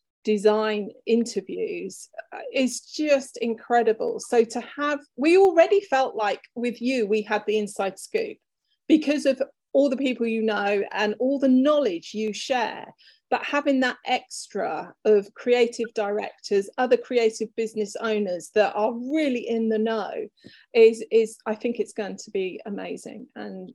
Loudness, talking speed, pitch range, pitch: -24 LUFS, 150 wpm, 215-270 Hz, 235 Hz